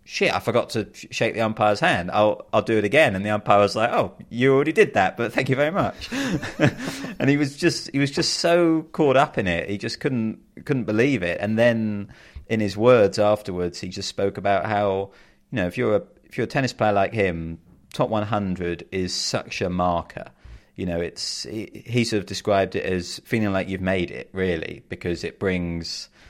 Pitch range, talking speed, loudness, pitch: 95-115 Hz, 215 wpm, -23 LUFS, 105 Hz